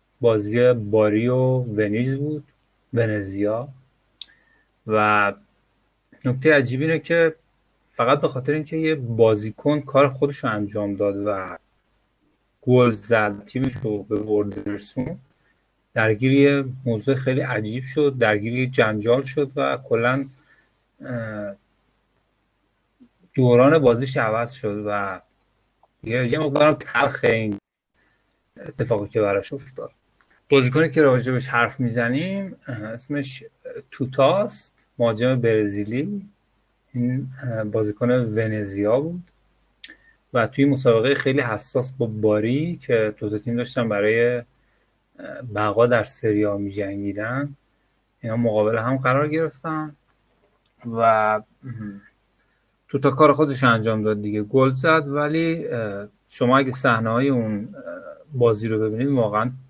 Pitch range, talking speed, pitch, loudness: 110-140 Hz, 105 wpm, 120 Hz, -21 LUFS